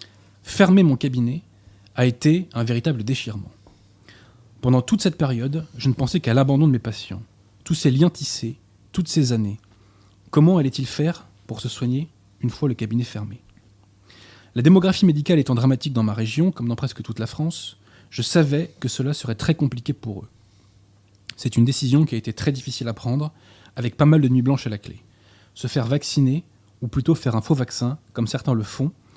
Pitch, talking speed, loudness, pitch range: 120 Hz, 190 wpm, -21 LUFS, 105-145 Hz